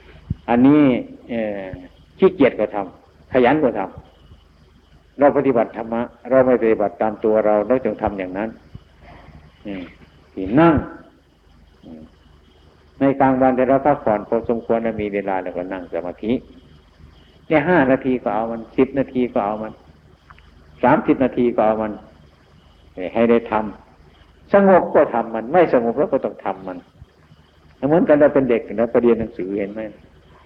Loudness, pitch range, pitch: -18 LUFS, 80-120 Hz, 105 Hz